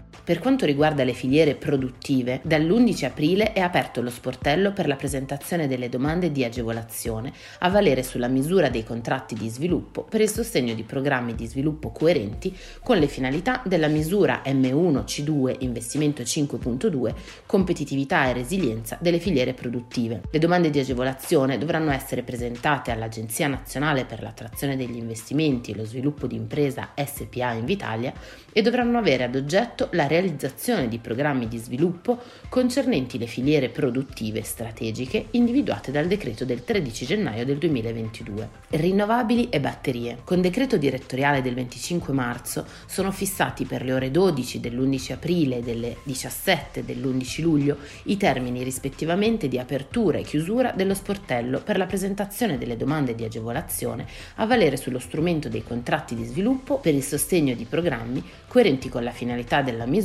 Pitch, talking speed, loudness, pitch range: 135 Hz, 150 wpm, -24 LUFS, 125-170 Hz